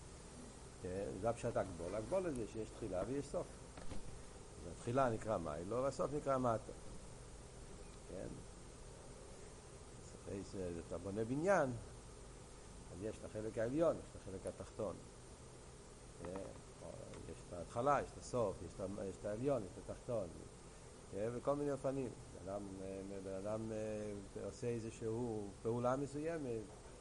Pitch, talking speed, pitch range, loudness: 110 Hz, 115 wpm, 100-120 Hz, -43 LUFS